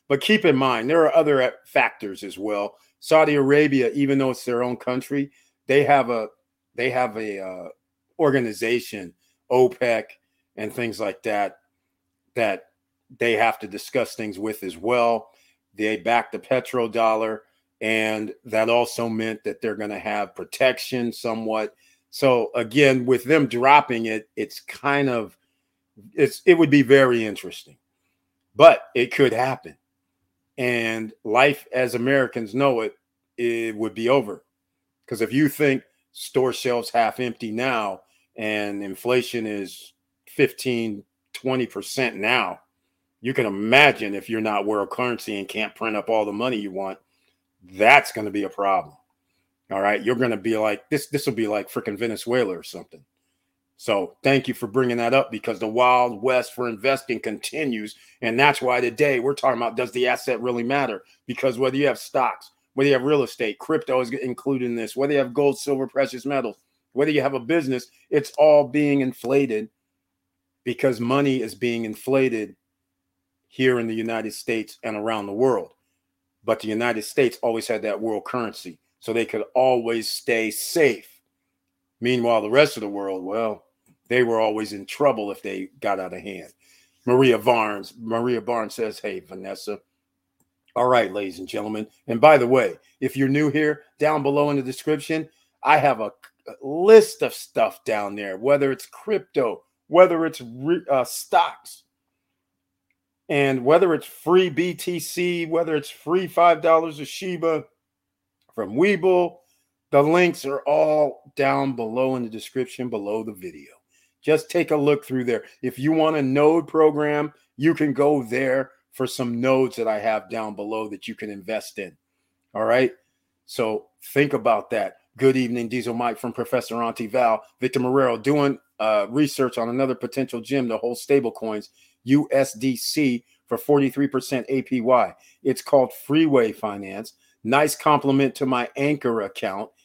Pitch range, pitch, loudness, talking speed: 110-140 Hz, 125 Hz, -22 LUFS, 160 wpm